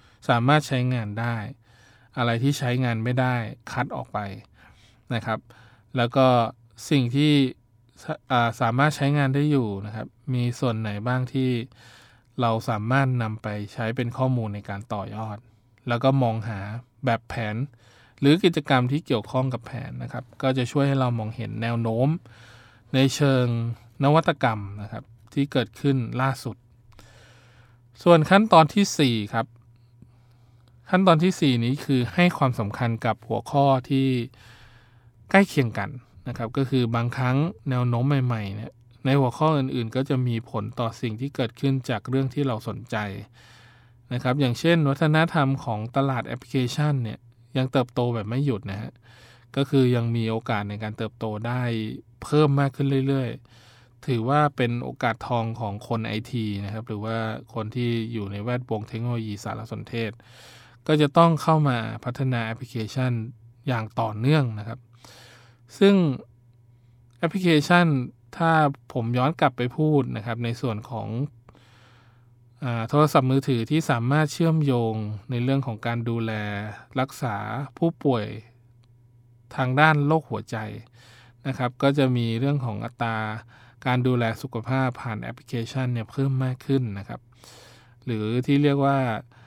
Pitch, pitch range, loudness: 120 Hz, 115-135 Hz, -24 LUFS